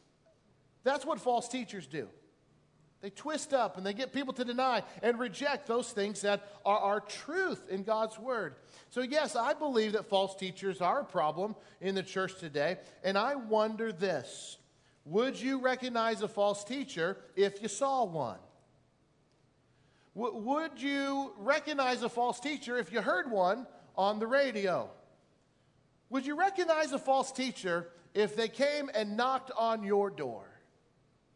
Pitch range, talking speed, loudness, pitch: 200-270 Hz, 155 wpm, -33 LUFS, 225 Hz